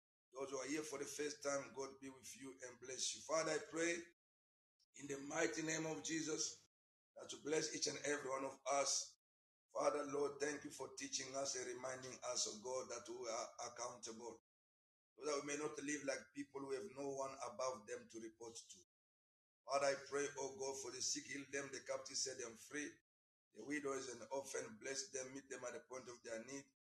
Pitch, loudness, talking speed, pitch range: 140 Hz, -46 LUFS, 210 wpm, 130-150 Hz